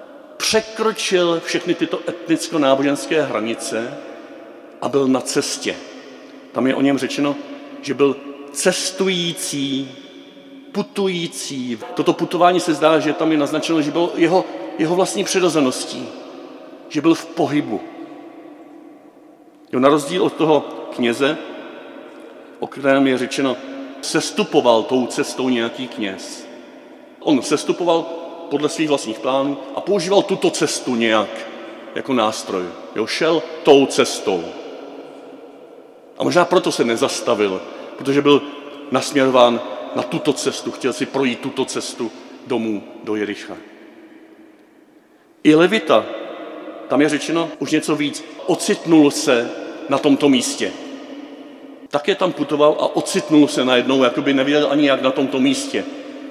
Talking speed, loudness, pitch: 125 wpm, -18 LUFS, 165 Hz